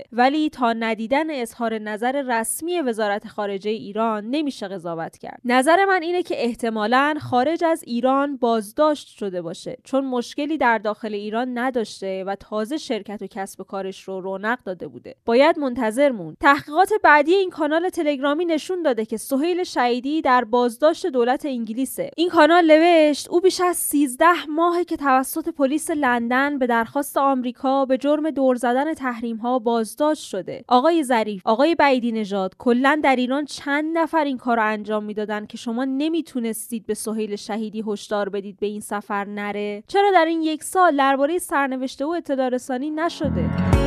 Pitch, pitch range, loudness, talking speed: 255 Hz, 220-305 Hz, -21 LUFS, 155 wpm